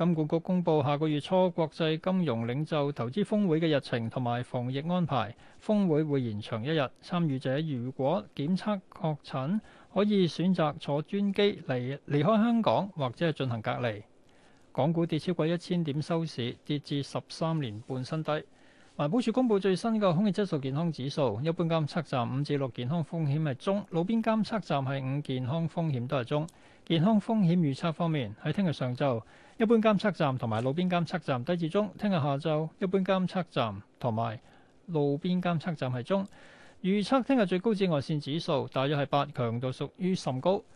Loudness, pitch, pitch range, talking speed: -30 LUFS, 160 Hz, 135-185 Hz, 285 characters per minute